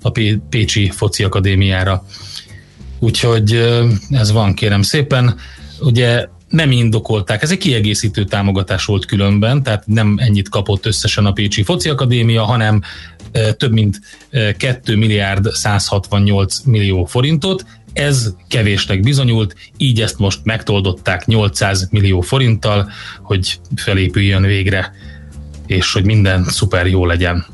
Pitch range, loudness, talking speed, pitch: 95-115 Hz, -14 LUFS, 120 wpm, 105 Hz